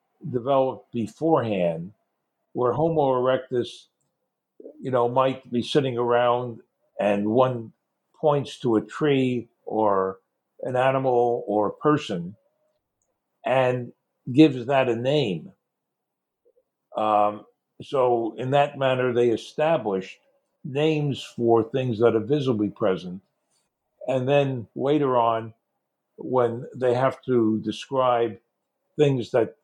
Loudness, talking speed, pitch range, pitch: -24 LUFS, 105 wpm, 115-145 Hz, 125 Hz